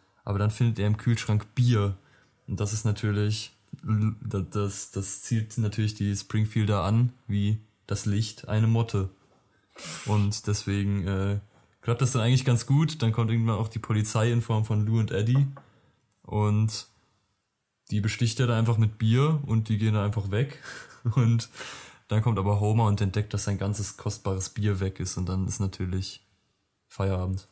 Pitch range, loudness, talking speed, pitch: 100-115 Hz, -27 LUFS, 170 wpm, 105 Hz